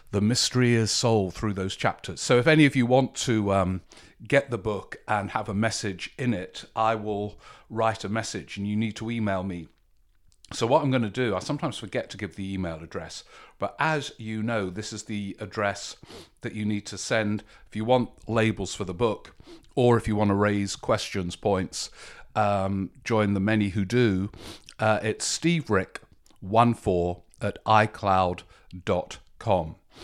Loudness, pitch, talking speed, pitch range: -26 LUFS, 110 Hz, 180 wpm, 100-115 Hz